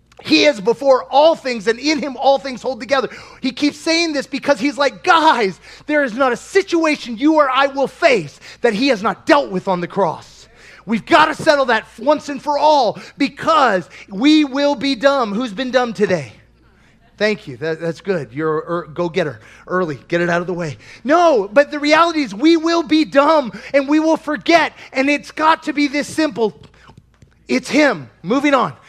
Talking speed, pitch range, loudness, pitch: 200 wpm, 195-300 Hz, -16 LUFS, 270 Hz